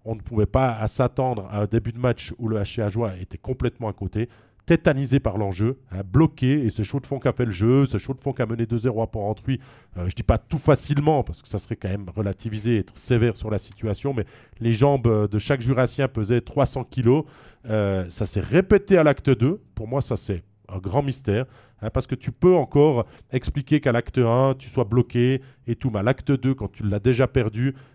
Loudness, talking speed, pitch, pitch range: -23 LUFS, 230 wpm, 120 Hz, 105-135 Hz